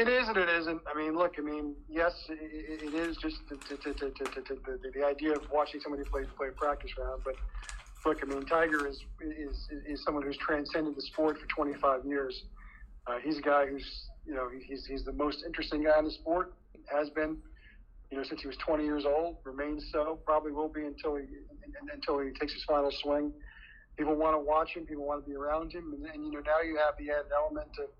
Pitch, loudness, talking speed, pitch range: 150 Hz, -34 LUFS, 230 wpm, 140-155 Hz